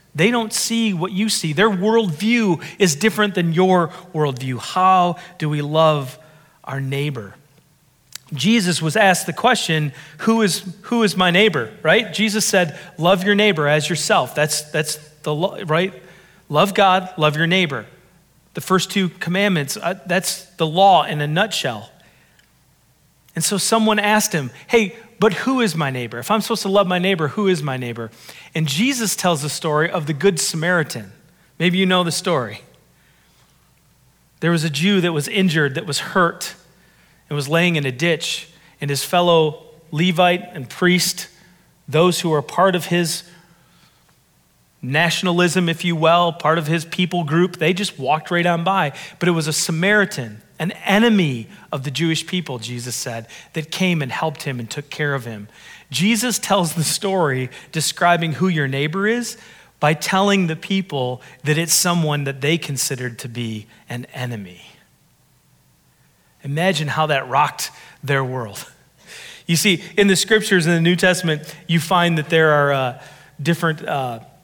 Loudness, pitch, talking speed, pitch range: -18 LUFS, 170 Hz, 165 wpm, 150-185 Hz